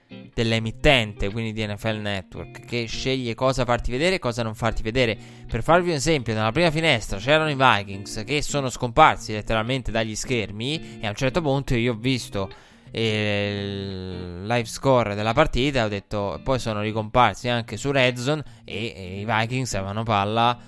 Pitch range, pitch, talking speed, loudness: 105-130 Hz, 115 Hz, 175 wpm, -23 LUFS